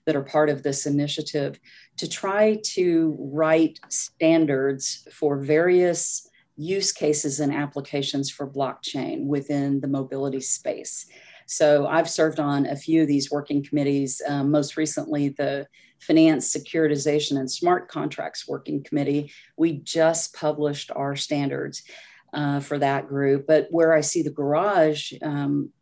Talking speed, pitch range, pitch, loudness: 140 wpm, 140-160 Hz, 145 Hz, -23 LUFS